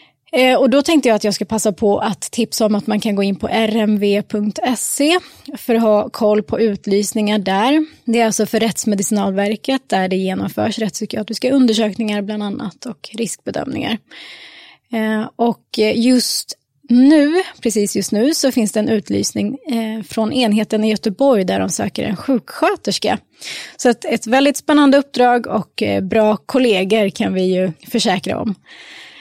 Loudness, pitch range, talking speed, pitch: -16 LUFS, 210-250 Hz, 150 wpm, 220 Hz